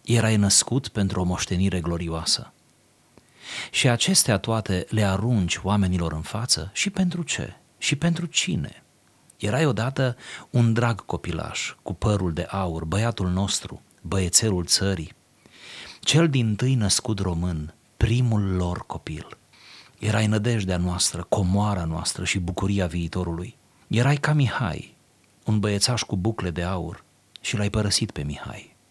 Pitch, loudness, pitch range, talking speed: 105 Hz, -24 LUFS, 90-115 Hz, 130 wpm